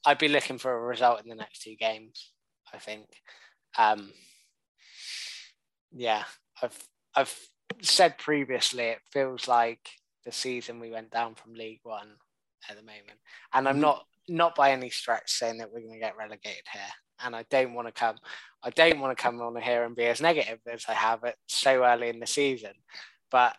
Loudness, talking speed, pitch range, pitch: -27 LUFS, 190 wpm, 115-130 Hz, 120 Hz